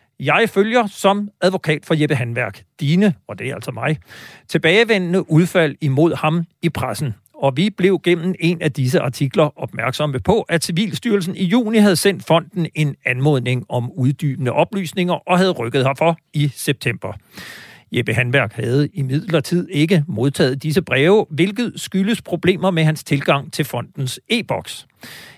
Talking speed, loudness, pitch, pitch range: 155 wpm, -18 LUFS, 160 Hz, 140-185 Hz